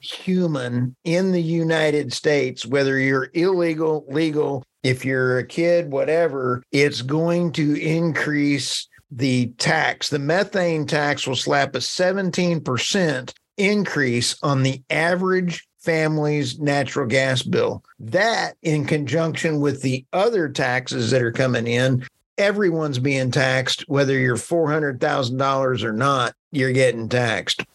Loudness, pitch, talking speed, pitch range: -21 LUFS, 145 Hz, 125 wpm, 130-165 Hz